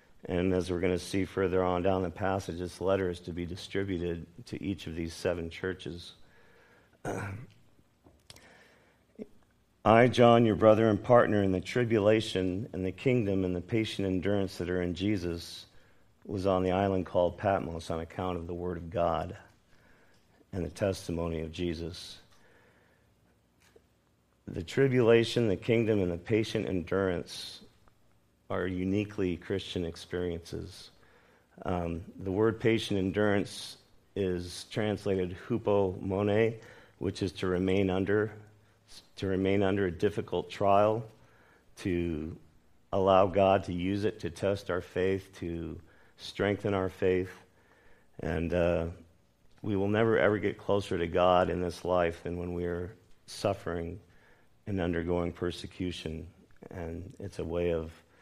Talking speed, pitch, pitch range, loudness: 140 wpm, 95 Hz, 85-100 Hz, -30 LUFS